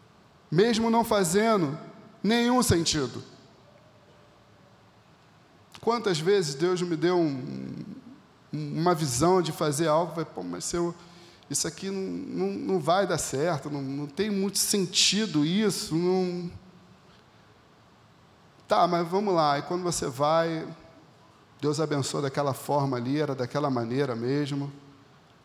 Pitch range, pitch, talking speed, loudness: 145-185 Hz, 165 Hz, 125 wpm, -26 LUFS